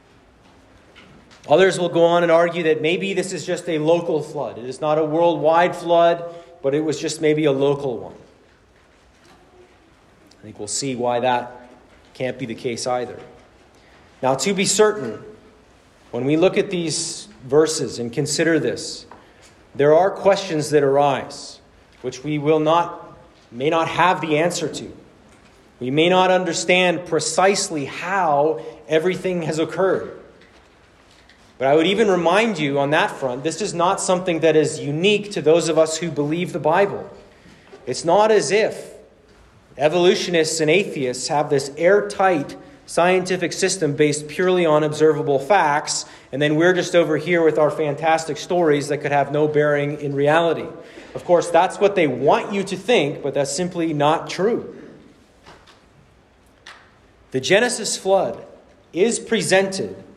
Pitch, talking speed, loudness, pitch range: 160 Hz, 155 wpm, -19 LUFS, 145-180 Hz